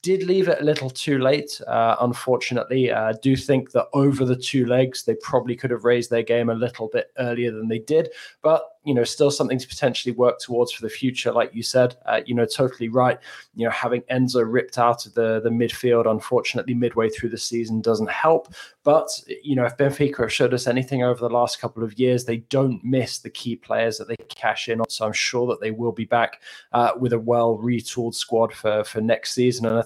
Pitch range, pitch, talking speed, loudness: 115-130 Hz, 120 Hz, 230 wpm, -22 LUFS